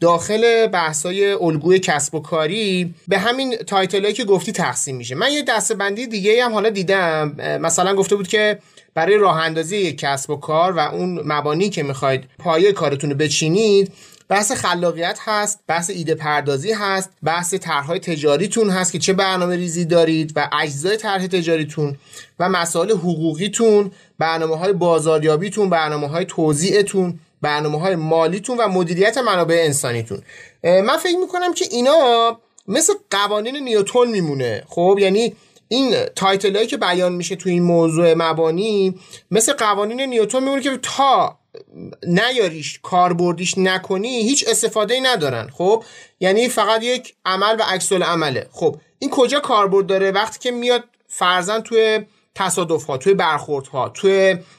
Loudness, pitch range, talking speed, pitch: -18 LUFS, 165-220 Hz, 150 wpm, 190 Hz